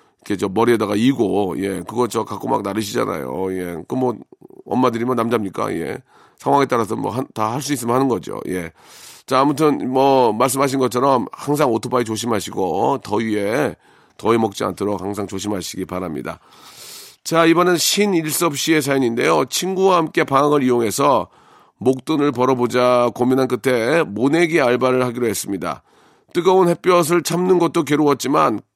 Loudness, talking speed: -18 LUFS, 345 characters per minute